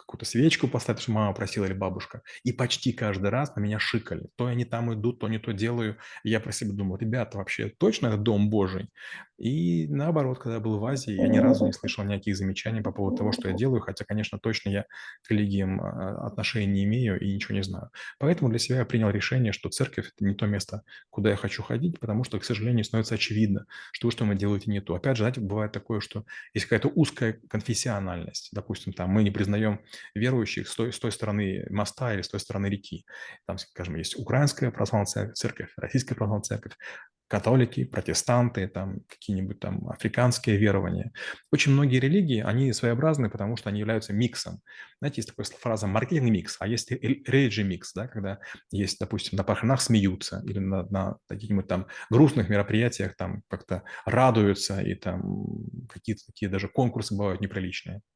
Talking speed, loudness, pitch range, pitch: 190 wpm, -27 LUFS, 100-120 Hz, 110 Hz